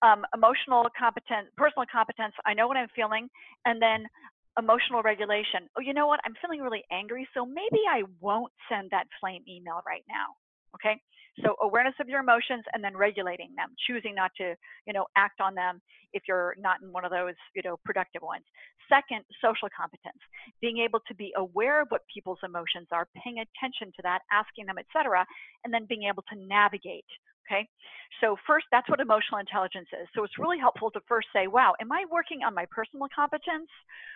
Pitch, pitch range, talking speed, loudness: 220 Hz, 195-255 Hz, 195 wpm, -28 LUFS